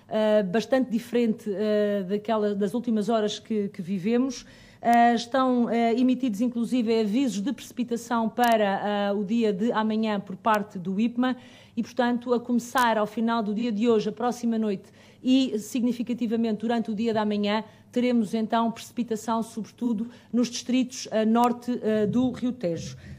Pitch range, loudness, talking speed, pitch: 215-240 Hz, -26 LUFS, 155 wpm, 230 Hz